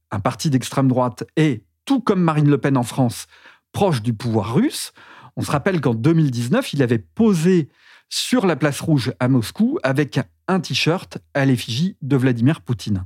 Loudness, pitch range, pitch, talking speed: -19 LUFS, 125-160 Hz, 140 Hz, 175 wpm